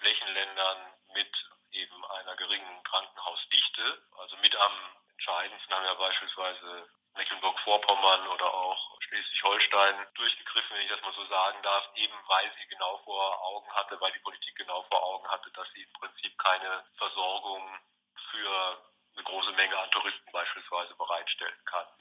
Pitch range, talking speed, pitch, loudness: 95-100 Hz, 145 wpm, 95 Hz, -30 LUFS